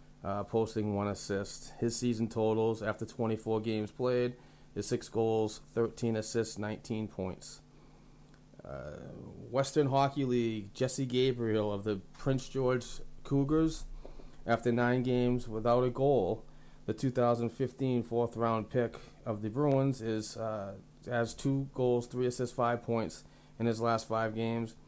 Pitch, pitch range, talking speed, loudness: 115 Hz, 110-125 Hz, 135 wpm, -33 LUFS